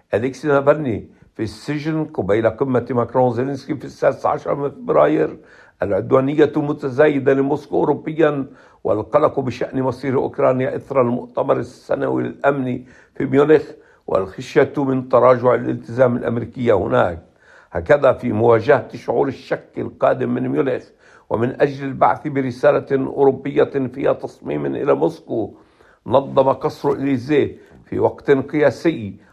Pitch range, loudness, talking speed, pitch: 125-145 Hz, -19 LUFS, 115 wpm, 135 Hz